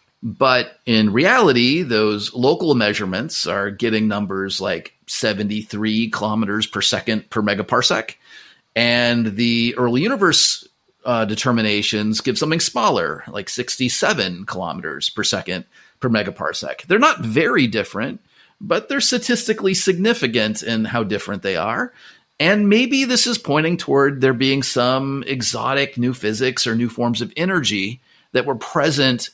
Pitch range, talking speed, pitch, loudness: 110-140 Hz, 135 wpm, 120 Hz, -18 LUFS